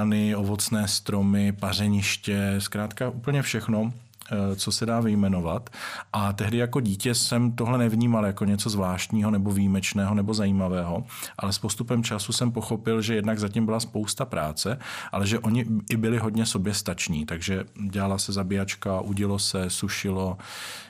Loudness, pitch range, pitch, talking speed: -26 LUFS, 100-115 Hz, 105 Hz, 145 wpm